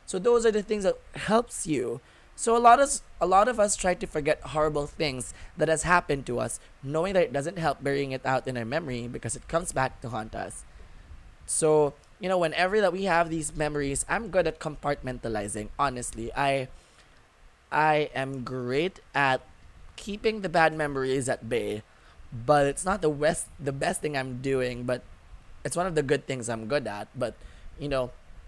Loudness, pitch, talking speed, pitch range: -27 LUFS, 145 Hz, 195 wpm, 125-165 Hz